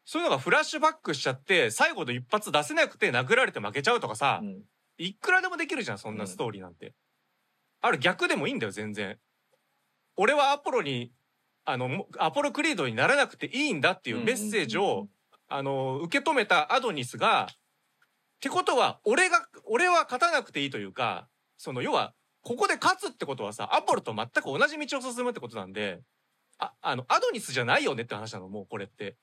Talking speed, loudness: 415 characters per minute, -27 LUFS